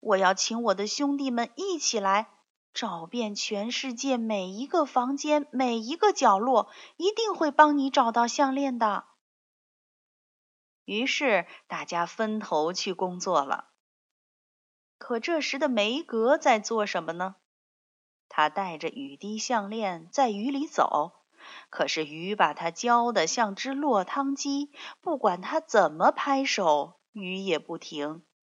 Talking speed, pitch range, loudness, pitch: 190 characters per minute, 190-280 Hz, -27 LUFS, 230 Hz